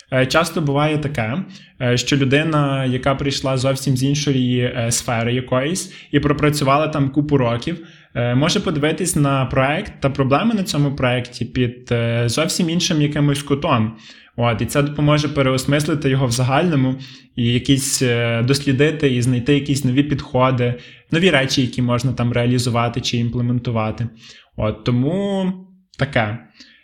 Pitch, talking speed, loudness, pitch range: 135 Hz, 125 wpm, -18 LUFS, 125-150 Hz